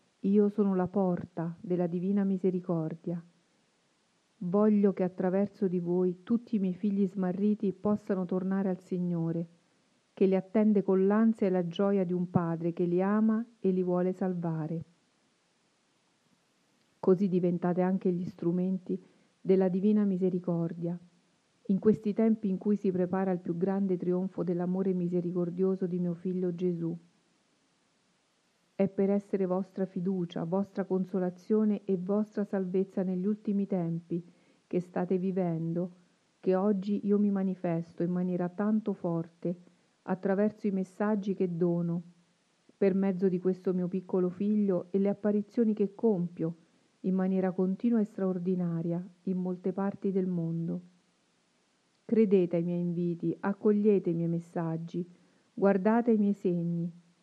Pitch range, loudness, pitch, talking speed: 180-200 Hz, -30 LUFS, 185 Hz, 135 wpm